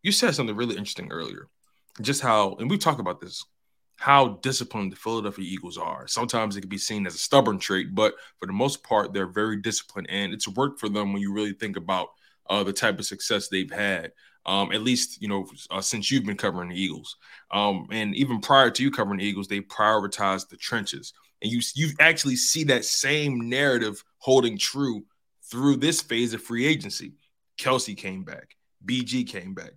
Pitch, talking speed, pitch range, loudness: 110 Hz, 200 wpm, 100-130 Hz, -25 LUFS